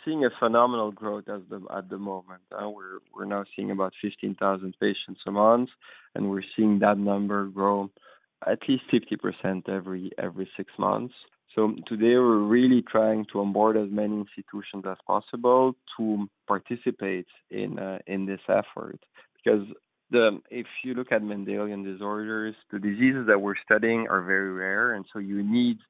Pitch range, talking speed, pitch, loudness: 95-110 Hz, 165 wpm, 105 Hz, -26 LUFS